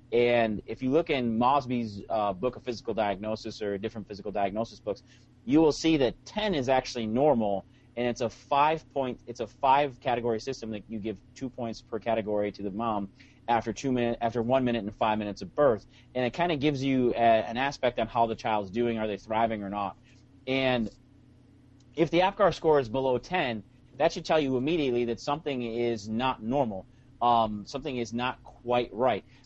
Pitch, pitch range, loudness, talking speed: 120 Hz, 110-130 Hz, -28 LUFS, 195 wpm